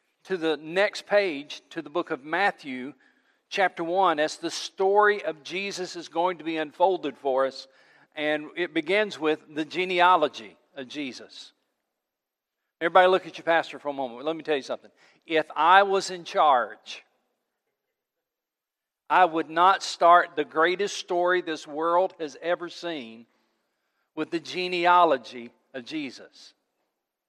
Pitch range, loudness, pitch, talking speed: 155-185 Hz, -25 LUFS, 170 Hz, 145 wpm